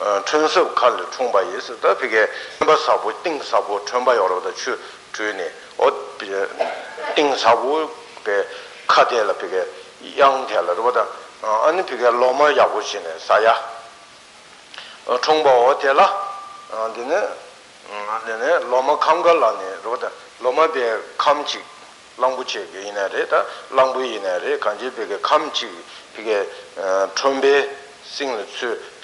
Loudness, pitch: -19 LUFS, 195 Hz